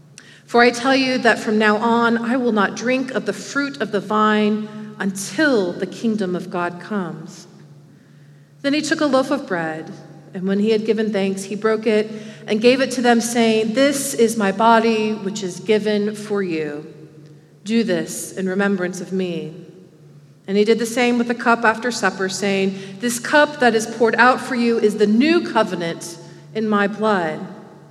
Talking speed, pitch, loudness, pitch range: 185 wpm, 210 Hz, -19 LUFS, 185-230 Hz